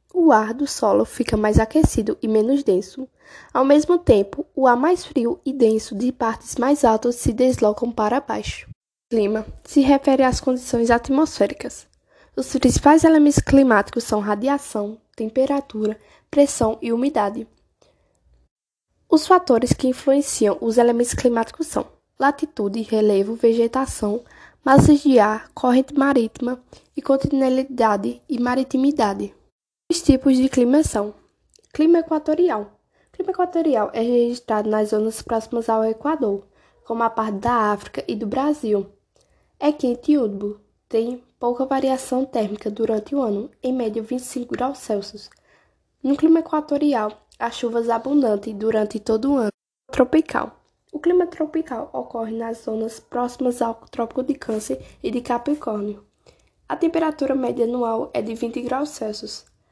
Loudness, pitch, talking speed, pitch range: -20 LUFS, 245 Hz, 140 wpm, 220-280 Hz